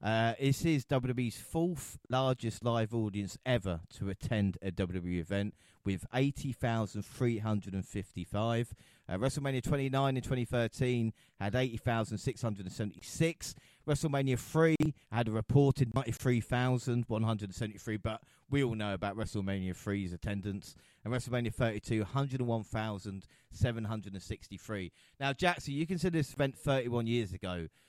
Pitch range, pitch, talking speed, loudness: 100-130 Hz, 115 Hz, 110 wpm, -34 LUFS